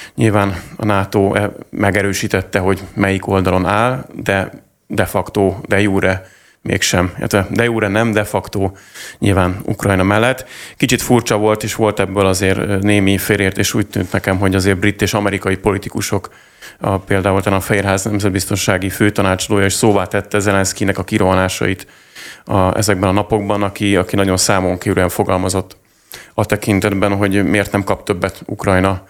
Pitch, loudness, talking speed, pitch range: 100 Hz, -15 LUFS, 145 wpm, 95-105 Hz